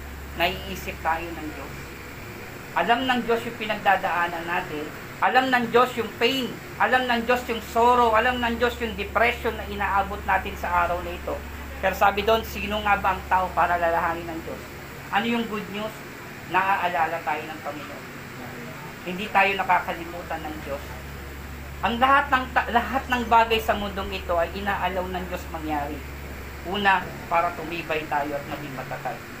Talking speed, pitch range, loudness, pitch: 160 wpm, 155-230 Hz, -24 LUFS, 185 Hz